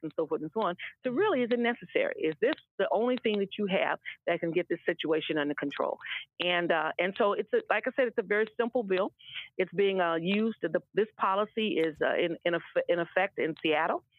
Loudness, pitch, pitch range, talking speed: -30 LUFS, 195 Hz, 170-240 Hz, 235 wpm